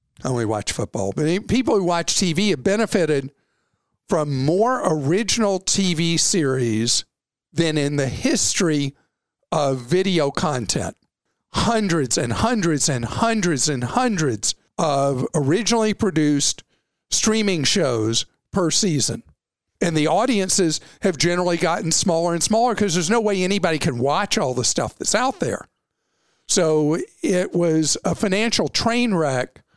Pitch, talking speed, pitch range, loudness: 170 Hz, 130 wpm, 140-200 Hz, -20 LUFS